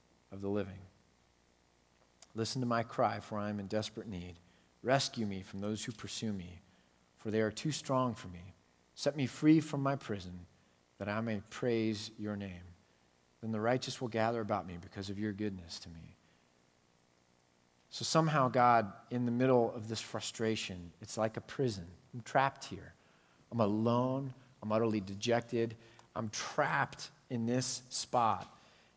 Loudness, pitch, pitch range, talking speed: -35 LUFS, 105 Hz, 90-120 Hz, 160 wpm